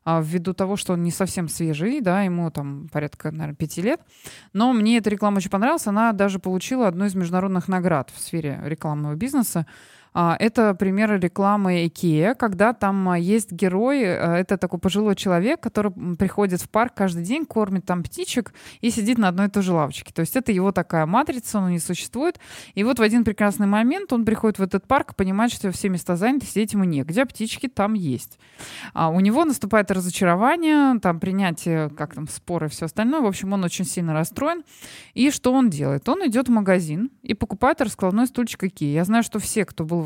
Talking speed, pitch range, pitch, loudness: 195 wpm, 175-230 Hz, 195 Hz, -22 LUFS